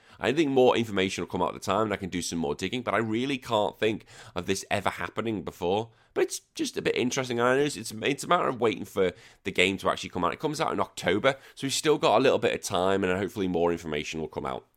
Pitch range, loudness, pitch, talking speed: 95-130 Hz, -27 LUFS, 110 Hz, 280 wpm